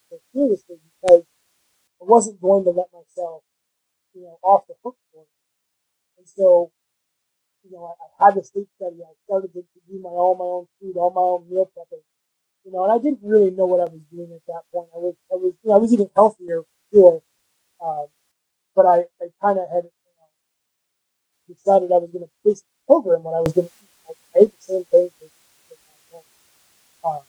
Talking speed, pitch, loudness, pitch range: 205 wpm, 180 Hz, -19 LUFS, 170-195 Hz